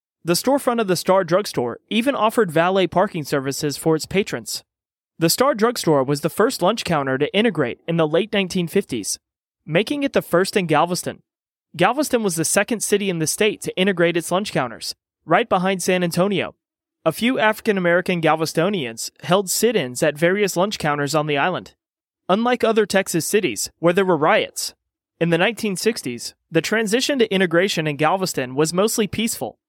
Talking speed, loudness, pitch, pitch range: 175 wpm, -20 LUFS, 185 Hz, 165-215 Hz